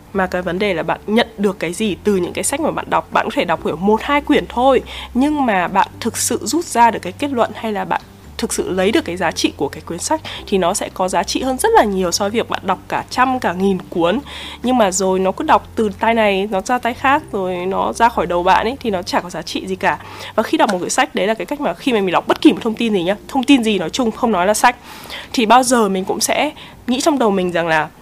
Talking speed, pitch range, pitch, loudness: 305 wpm, 190-250 Hz, 220 Hz, -17 LUFS